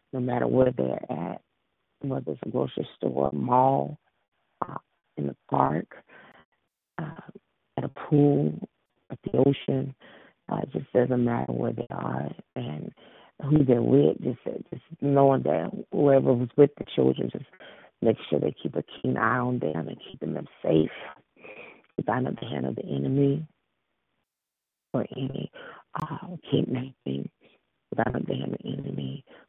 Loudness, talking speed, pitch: -27 LUFS, 155 wpm, 125 Hz